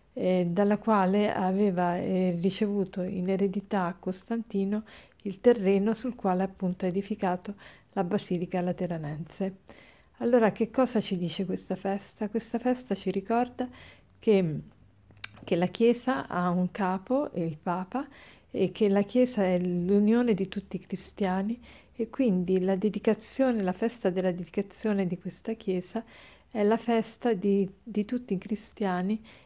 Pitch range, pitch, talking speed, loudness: 185-225 Hz, 195 Hz, 140 wpm, -29 LUFS